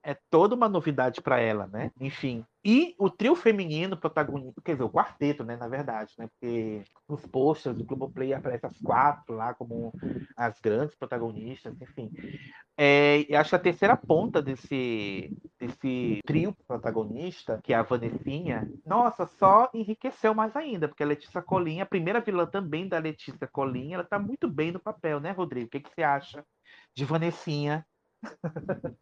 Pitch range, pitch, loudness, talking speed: 125-180 Hz, 145 Hz, -28 LUFS, 170 wpm